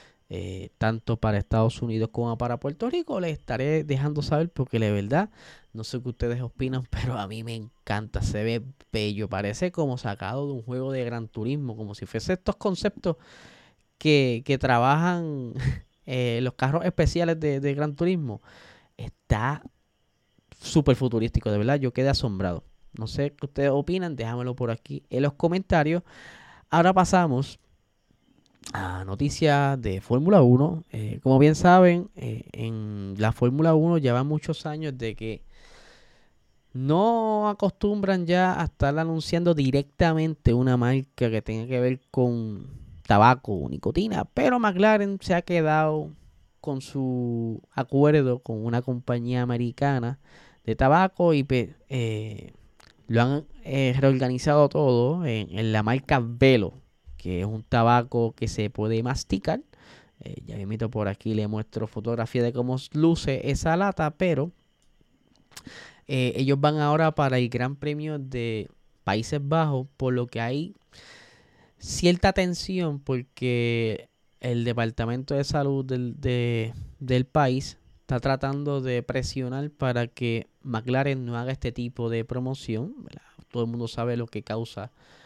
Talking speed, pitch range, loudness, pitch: 145 wpm, 115-150 Hz, -25 LUFS, 130 Hz